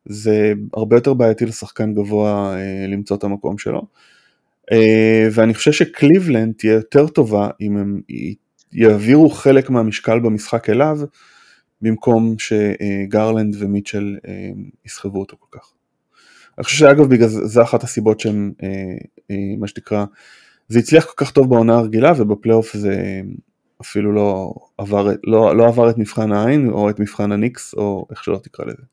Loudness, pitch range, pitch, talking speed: -15 LUFS, 105-115 Hz, 110 Hz, 150 wpm